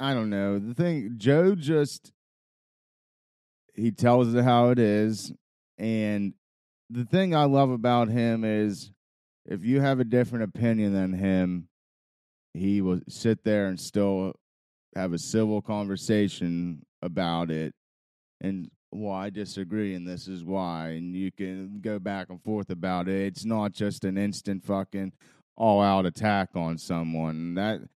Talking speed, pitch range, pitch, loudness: 150 wpm, 90-110 Hz, 100 Hz, -27 LUFS